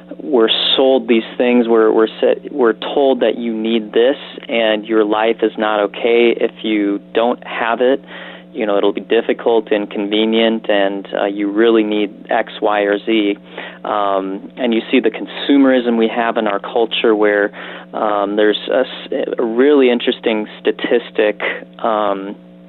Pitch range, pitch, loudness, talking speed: 100-115 Hz, 110 Hz, -15 LUFS, 160 wpm